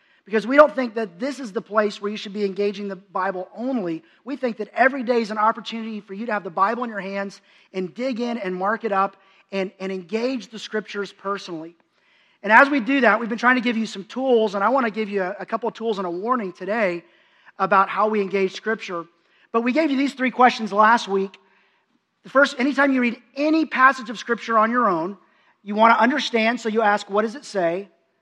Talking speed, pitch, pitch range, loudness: 240 wpm, 220 Hz, 195-245 Hz, -21 LUFS